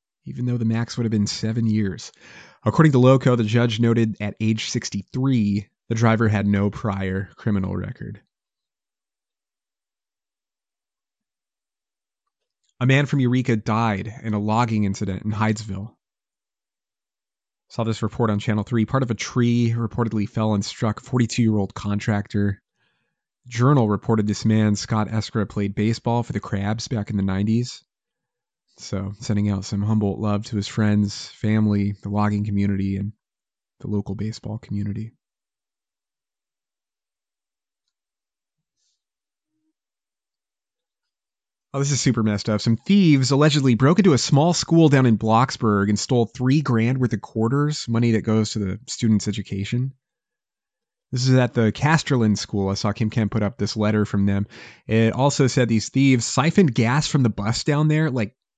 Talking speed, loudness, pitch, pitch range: 150 wpm, -21 LUFS, 110 Hz, 105-125 Hz